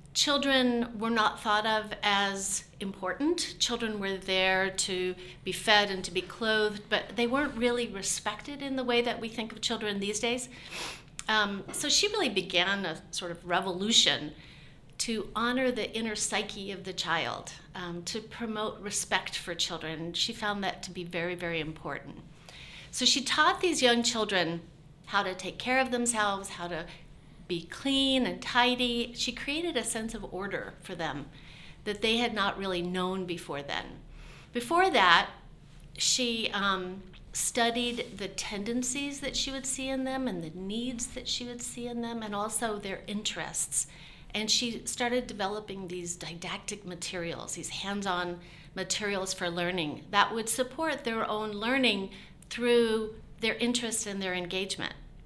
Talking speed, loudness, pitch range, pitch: 160 wpm, -30 LUFS, 180-235 Hz, 205 Hz